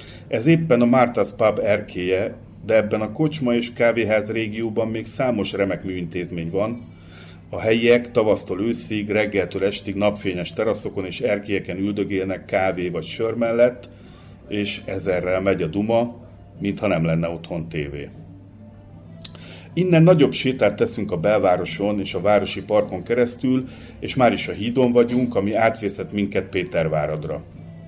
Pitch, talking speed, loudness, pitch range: 105 Hz, 140 wpm, -21 LUFS, 90-115 Hz